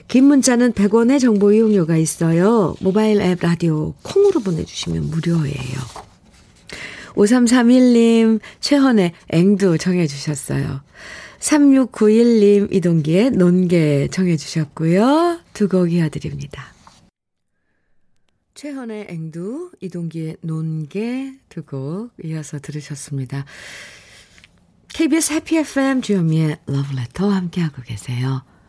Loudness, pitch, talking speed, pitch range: -17 LUFS, 180 Hz, 240 characters per minute, 155-230 Hz